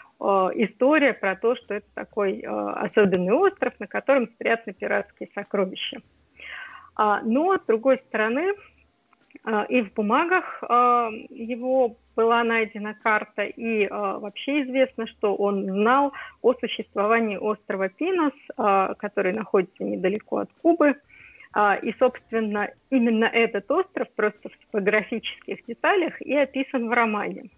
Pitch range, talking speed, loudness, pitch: 210-270 Hz, 115 wpm, -24 LUFS, 230 Hz